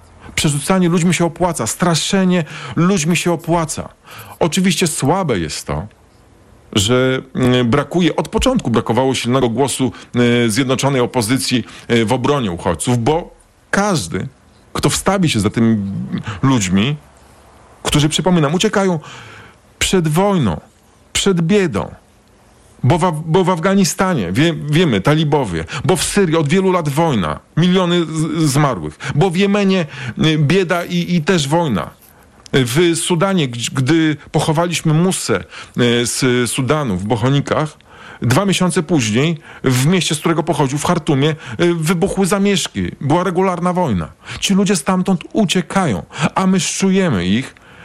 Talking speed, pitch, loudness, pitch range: 120 wpm, 160 Hz, -16 LUFS, 125-185 Hz